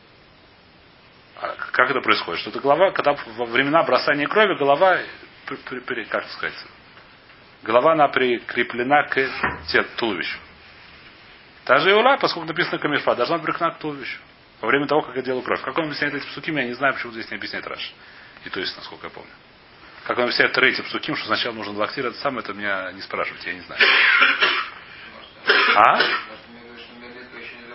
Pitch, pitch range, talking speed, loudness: 135 Hz, 120-150 Hz, 165 wpm, -20 LUFS